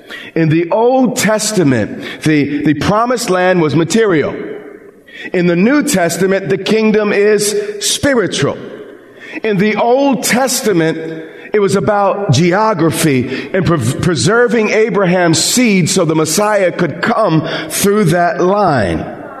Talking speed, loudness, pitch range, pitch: 120 wpm, -12 LUFS, 165-215 Hz, 195 Hz